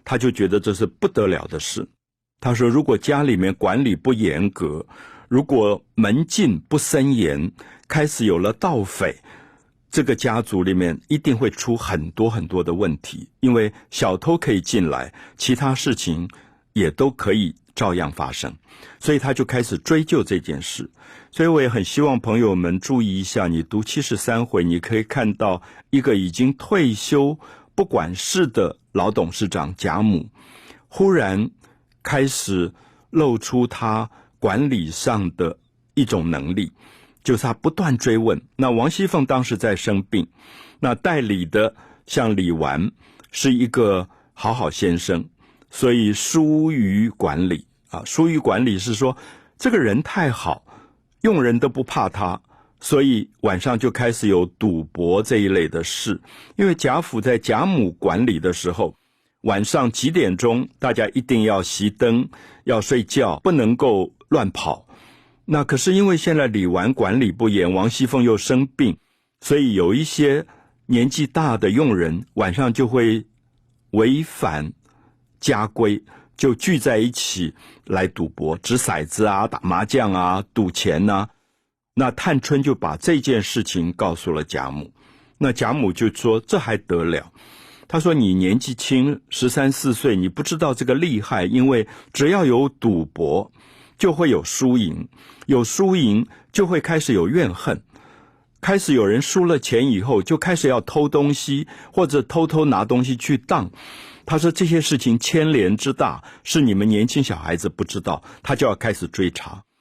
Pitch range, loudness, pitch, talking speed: 100-140 Hz, -20 LUFS, 120 Hz, 225 characters per minute